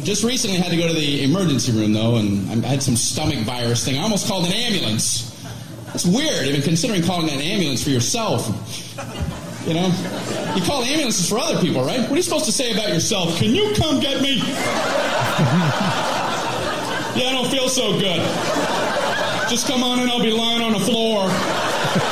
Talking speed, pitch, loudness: 195 wpm, 185 Hz, -19 LUFS